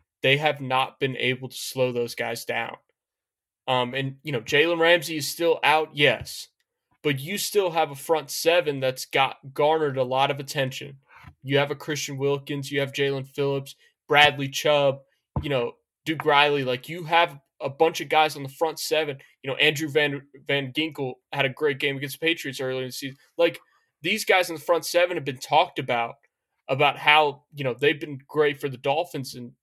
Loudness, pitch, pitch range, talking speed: -24 LUFS, 145 Hz, 135-155 Hz, 200 wpm